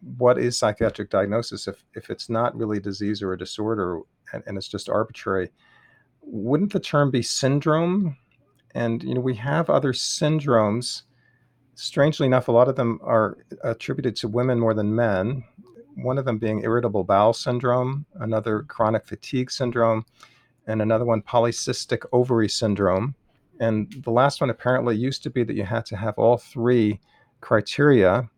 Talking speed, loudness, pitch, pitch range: 160 wpm, -23 LUFS, 120 Hz, 110-130 Hz